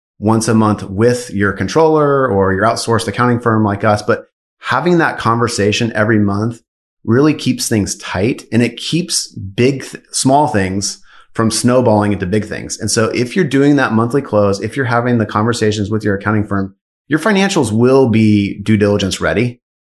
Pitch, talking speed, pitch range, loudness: 110 Hz, 180 wpm, 105-125 Hz, -14 LUFS